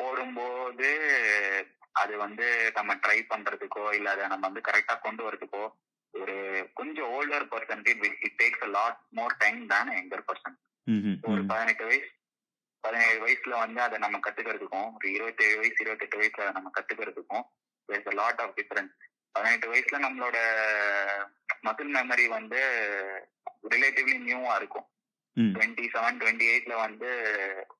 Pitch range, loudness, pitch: 100-120 Hz, -28 LUFS, 110 Hz